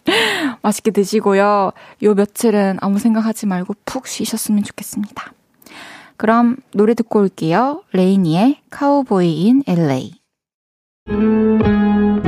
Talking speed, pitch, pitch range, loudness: 240 characters per minute, 210 Hz, 200-230 Hz, -16 LUFS